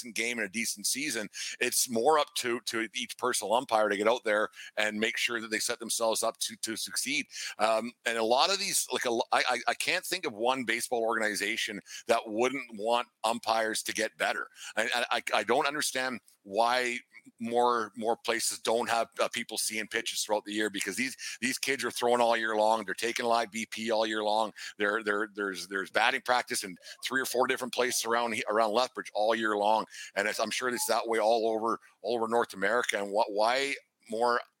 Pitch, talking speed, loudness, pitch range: 115 Hz, 210 wpm, -30 LUFS, 110-120 Hz